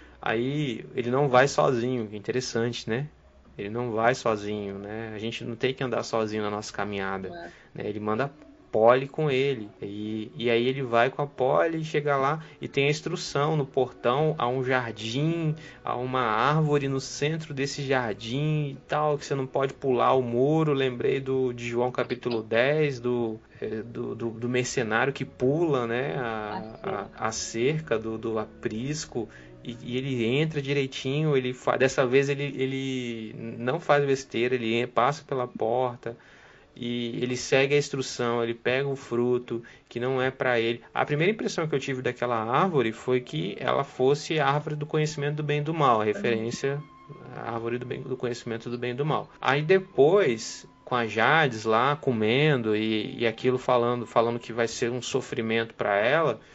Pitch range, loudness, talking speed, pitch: 115-140 Hz, -27 LUFS, 180 wpm, 125 Hz